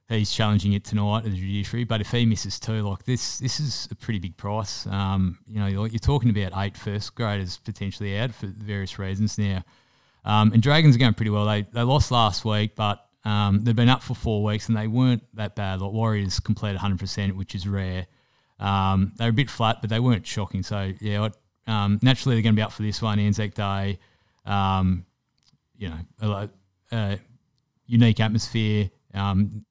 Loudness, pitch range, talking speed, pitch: -24 LUFS, 100-115 Hz, 205 wpm, 105 Hz